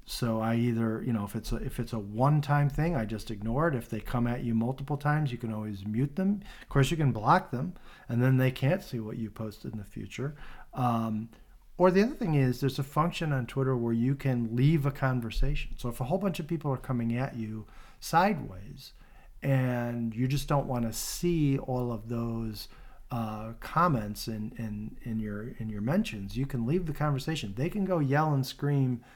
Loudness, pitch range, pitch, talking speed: -30 LUFS, 115-145 Hz, 125 Hz, 220 wpm